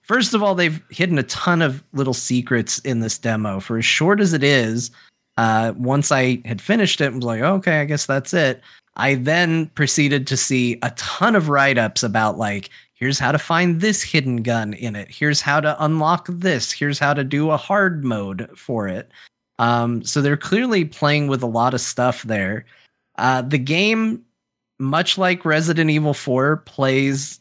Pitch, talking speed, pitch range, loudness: 140 Hz, 195 wpm, 120-160 Hz, -19 LUFS